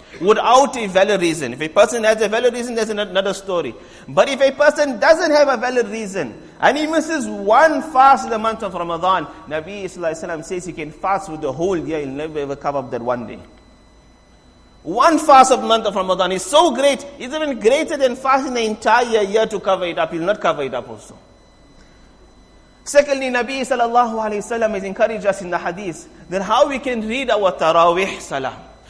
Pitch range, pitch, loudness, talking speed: 180-260 Hz, 215 Hz, -17 LUFS, 200 wpm